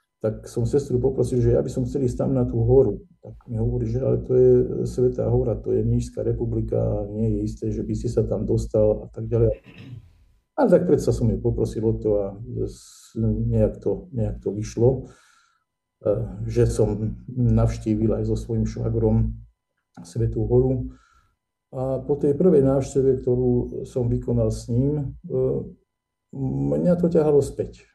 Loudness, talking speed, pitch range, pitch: -23 LUFS, 165 wpm, 110-125 Hz, 115 Hz